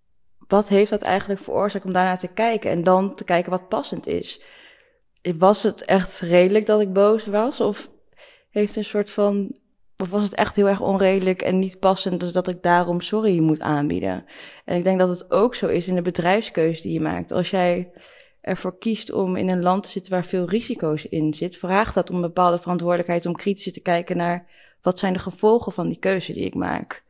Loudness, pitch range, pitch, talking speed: -21 LUFS, 175-205 Hz, 185 Hz, 210 wpm